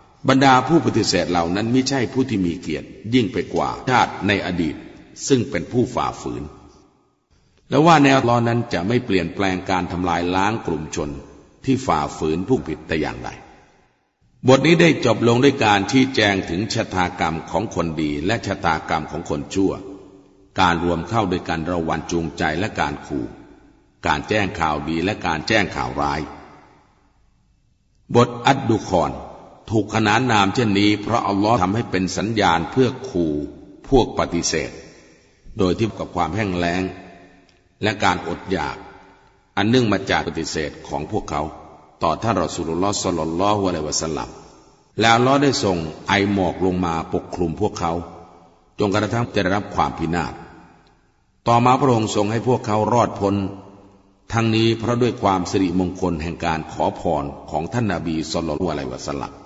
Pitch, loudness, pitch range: 95 Hz, -20 LUFS, 85-115 Hz